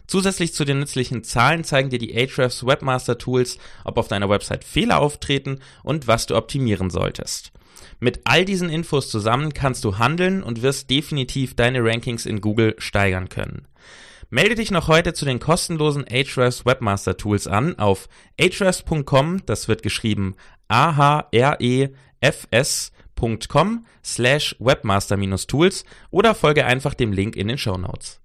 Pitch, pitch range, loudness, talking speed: 130 Hz, 110-150 Hz, -20 LUFS, 140 wpm